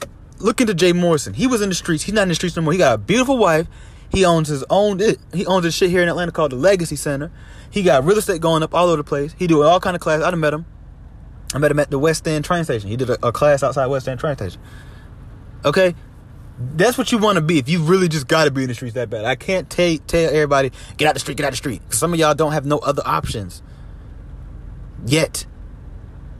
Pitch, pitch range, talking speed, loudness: 155 Hz, 135-175 Hz, 265 wpm, -18 LUFS